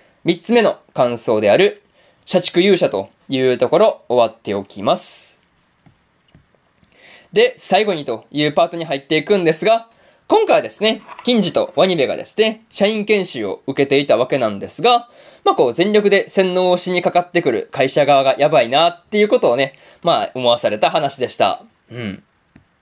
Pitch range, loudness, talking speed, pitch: 160-225 Hz, -16 LUFS, 330 characters per minute, 190 Hz